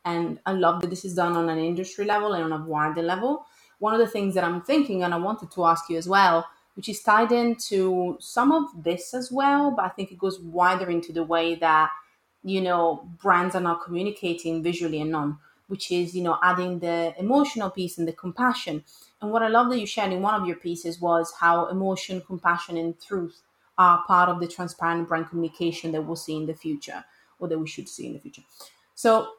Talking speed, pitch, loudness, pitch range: 225 wpm, 180 Hz, -24 LUFS, 170-195 Hz